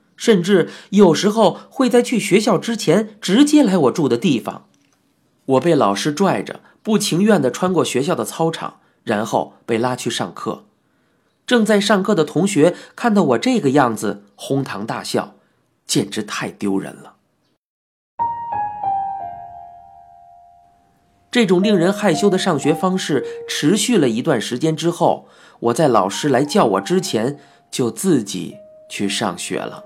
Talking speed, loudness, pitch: 210 characters per minute, -18 LUFS, 185 Hz